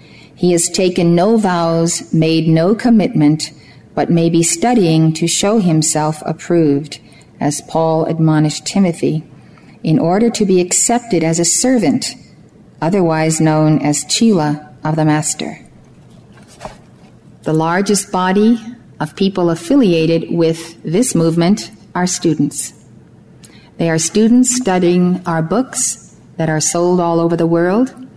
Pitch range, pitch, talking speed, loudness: 160-195 Hz, 170 Hz, 125 wpm, -14 LUFS